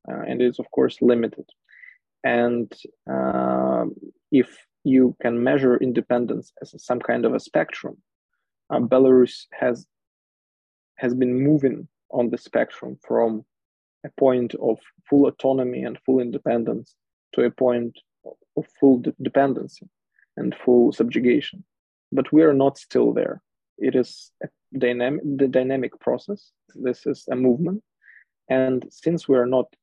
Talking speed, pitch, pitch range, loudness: 140 wpm, 125 Hz, 120-135 Hz, -22 LUFS